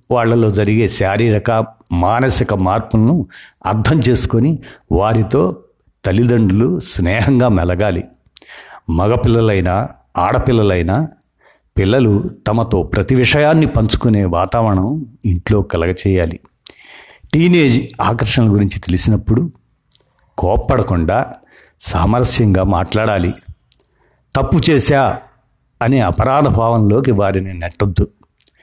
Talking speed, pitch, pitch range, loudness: 75 wpm, 110 Hz, 95-120 Hz, -14 LUFS